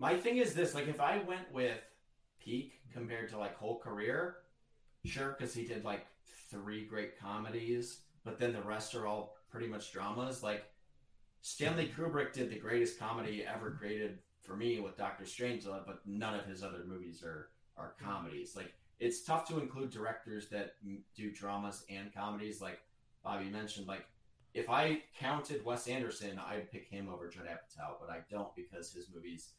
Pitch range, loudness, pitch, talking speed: 100-125 Hz, -41 LUFS, 110 Hz, 175 wpm